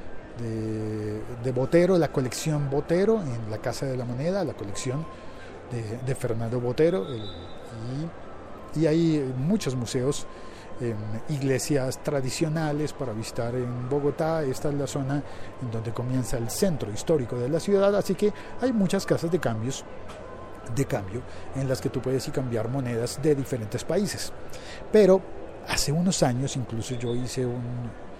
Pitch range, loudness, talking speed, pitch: 115-155 Hz, -27 LUFS, 150 wpm, 130 Hz